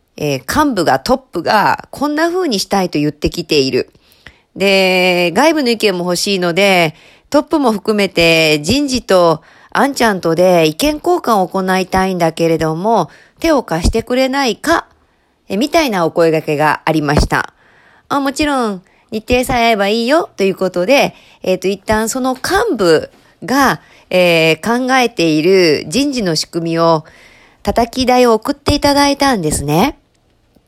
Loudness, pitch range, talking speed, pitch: -13 LUFS, 170-260 Hz, 300 characters per minute, 200 Hz